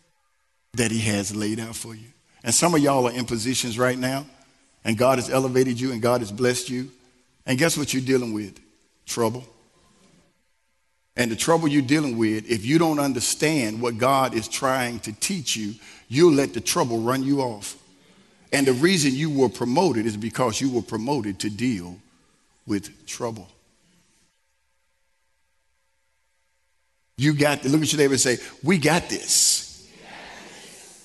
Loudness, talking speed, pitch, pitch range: -22 LUFS, 160 wpm, 125 Hz, 105-135 Hz